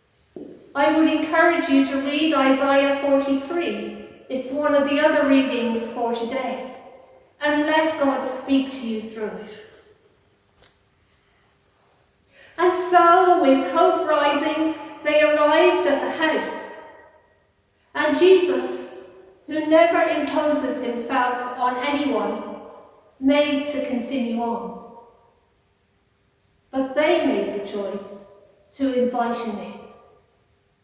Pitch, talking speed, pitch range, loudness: 275 Hz, 105 wpm, 235-300 Hz, -20 LUFS